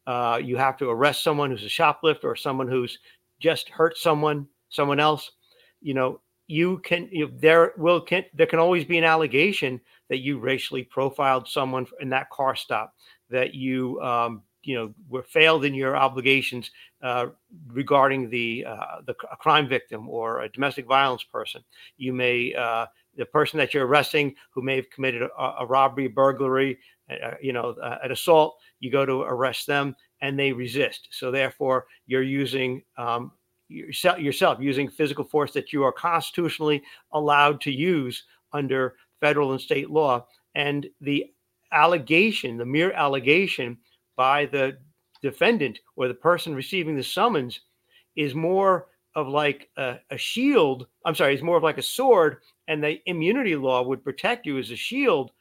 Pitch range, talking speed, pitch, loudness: 130-155 Hz, 165 wpm, 140 Hz, -24 LUFS